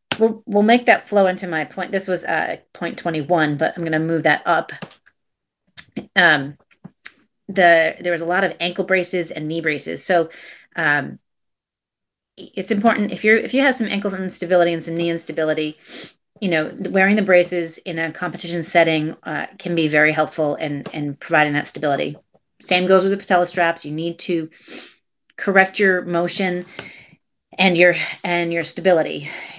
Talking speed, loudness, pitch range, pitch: 170 wpm, -19 LUFS, 165-190 Hz, 175 Hz